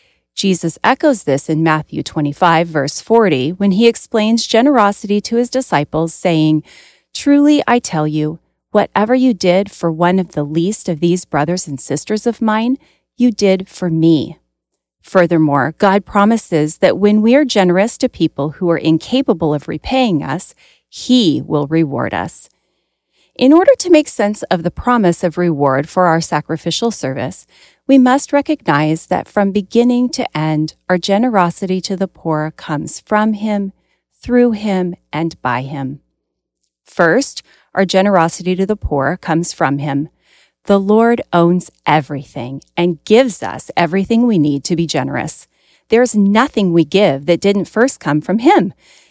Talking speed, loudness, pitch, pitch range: 155 wpm, -14 LUFS, 185 Hz, 160-230 Hz